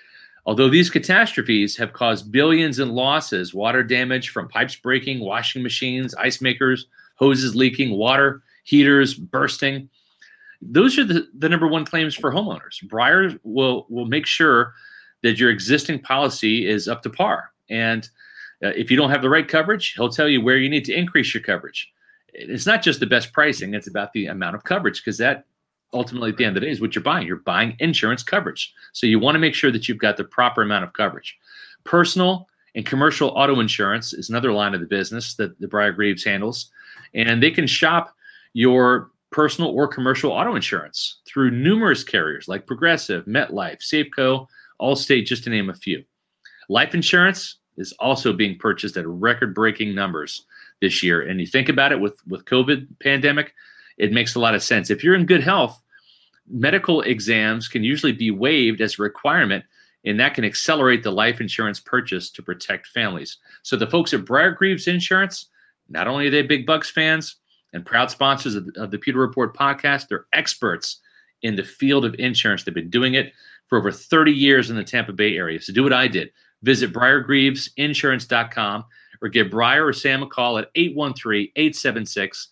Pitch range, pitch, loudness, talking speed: 115-150 Hz, 130 Hz, -19 LUFS, 185 wpm